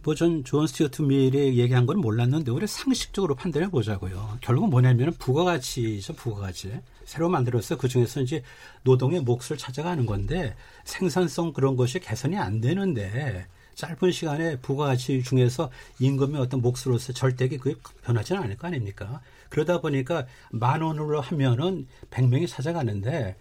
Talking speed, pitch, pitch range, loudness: 355 characters per minute, 130 Hz, 120-155 Hz, -26 LUFS